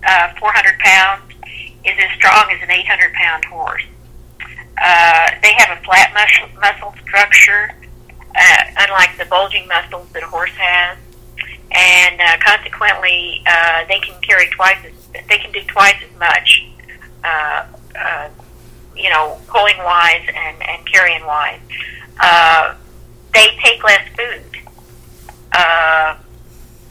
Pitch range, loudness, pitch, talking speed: 140-195 Hz, -10 LUFS, 175 Hz, 130 wpm